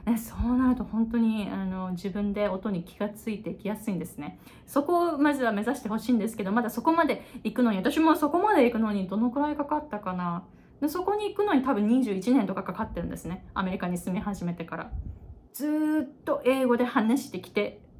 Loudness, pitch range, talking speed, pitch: -28 LUFS, 200-275 Hz, 405 characters per minute, 225 Hz